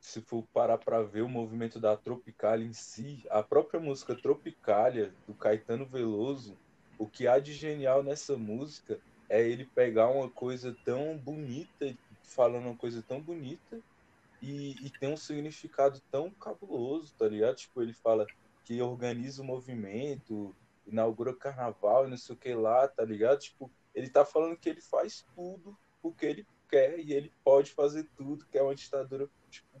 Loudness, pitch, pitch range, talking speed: -32 LUFS, 135 Hz, 115-145 Hz, 170 wpm